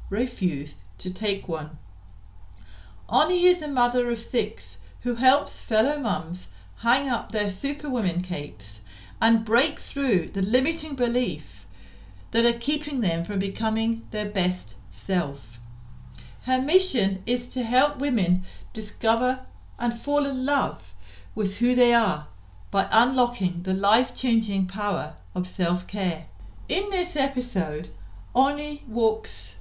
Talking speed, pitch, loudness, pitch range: 130 wpm, 210 Hz, -25 LUFS, 145-245 Hz